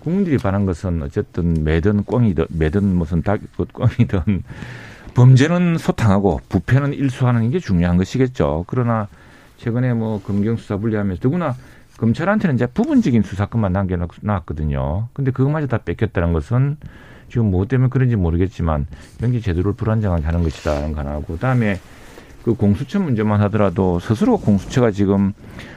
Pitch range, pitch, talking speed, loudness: 90-125 Hz, 105 Hz, 365 characters per minute, -19 LUFS